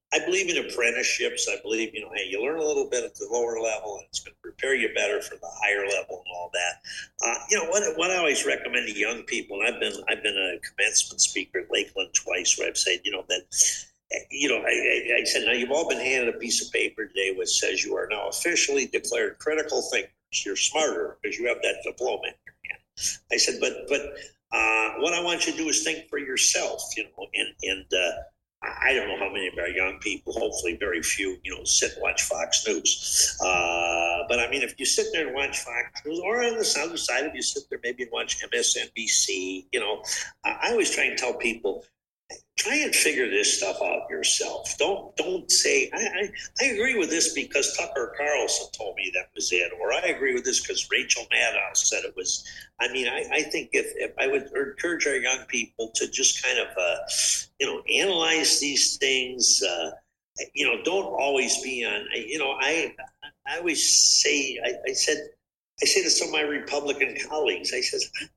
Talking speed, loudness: 220 wpm, -24 LUFS